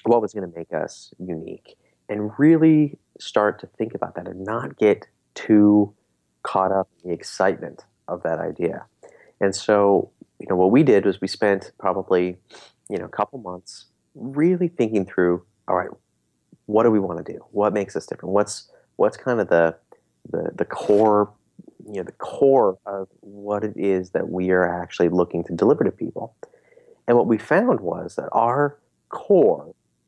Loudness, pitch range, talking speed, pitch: -21 LUFS, 90-110 Hz, 180 wpm, 100 Hz